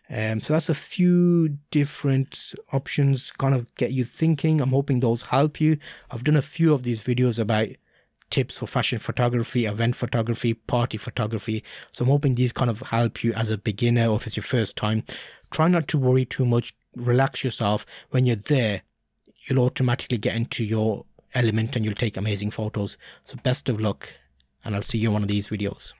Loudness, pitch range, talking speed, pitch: -24 LUFS, 110-135 Hz, 200 wpm, 120 Hz